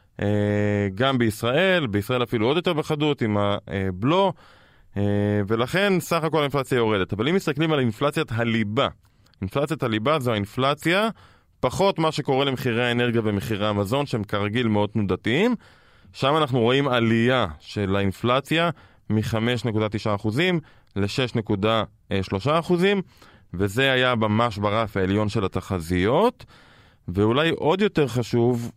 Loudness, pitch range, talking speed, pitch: -23 LUFS, 105-140 Hz, 115 wpm, 115 Hz